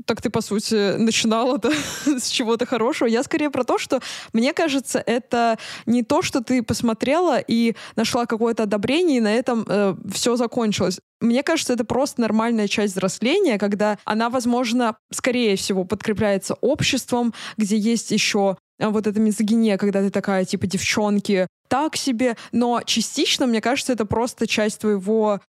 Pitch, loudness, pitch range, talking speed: 230 Hz, -21 LUFS, 210-250 Hz, 160 wpm